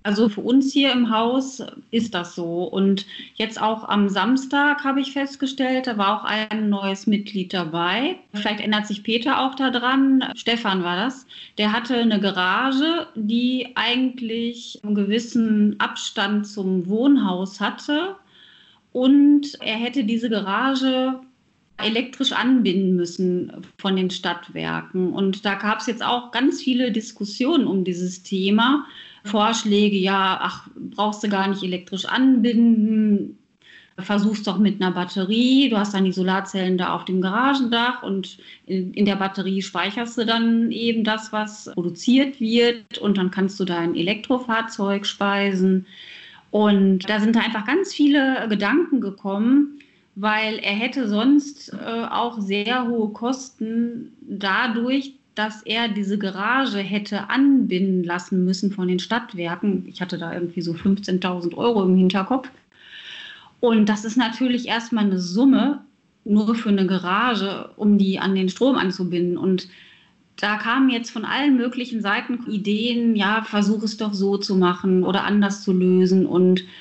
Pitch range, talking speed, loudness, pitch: 195-245 Hz, 145 wpm, -21 LUFS, 215 Hz